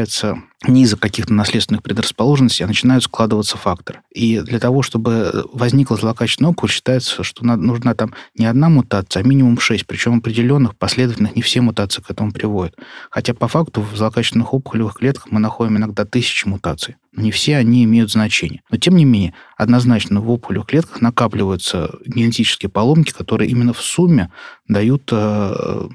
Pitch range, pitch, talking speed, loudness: 105-125 Hz, 115 Hz, 165 wpm, -16 LUFS